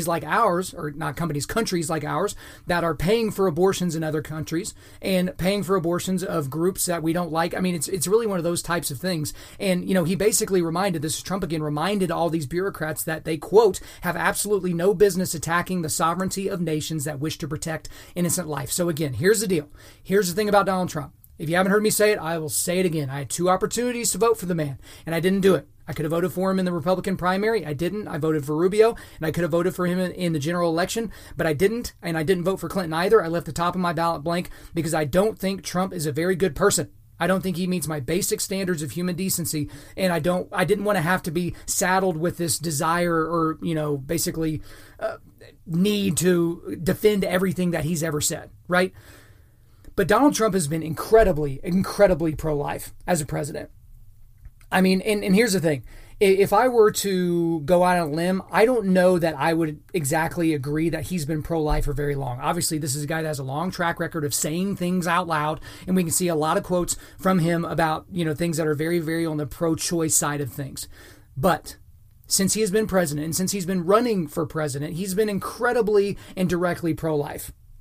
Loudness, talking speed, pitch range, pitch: -23 LUFS, 230 wpm, 155-190 Hz, 170 Hz